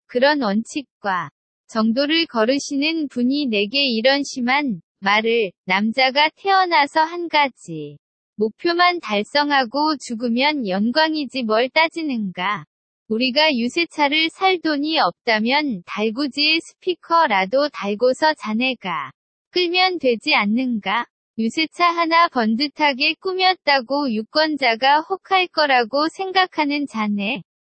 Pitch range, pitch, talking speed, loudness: 230-315 Hz, 280 Hz, 245 characters per minute, -19 LUFS